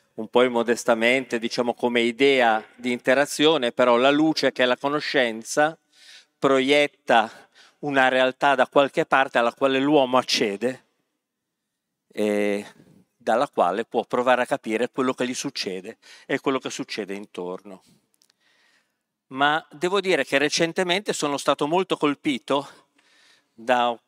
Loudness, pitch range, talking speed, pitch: -22 LUFS, 120-145 Hz, 130 wpm, 130 Hz